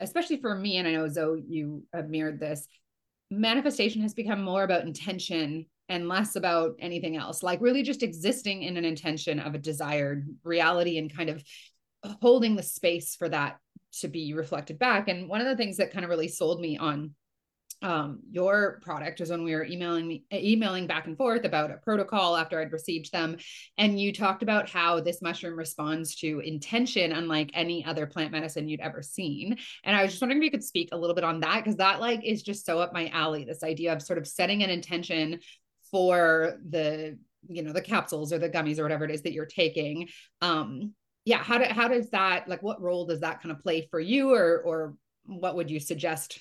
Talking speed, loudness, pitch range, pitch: 210 wpm, -28 LUFS, 160-200 Hz, 170 Hz